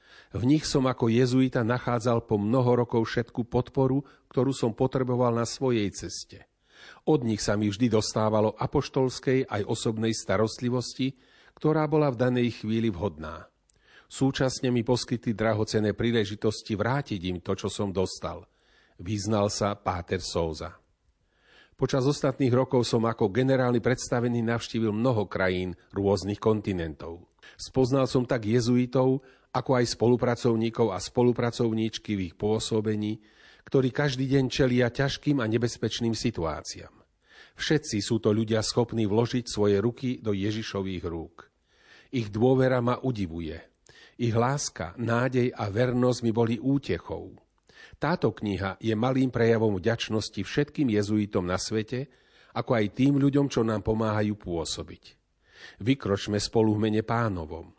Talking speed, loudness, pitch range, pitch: 130 wpm, -27 LUFS, 105-125 Hz, 115 Hz